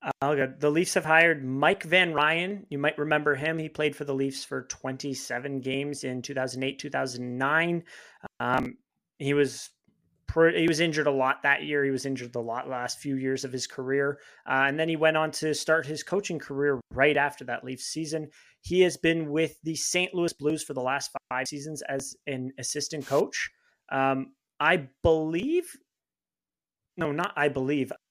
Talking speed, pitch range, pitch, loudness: 185 wpm, 135-160 Hz, 145 Hz, -27 LUFS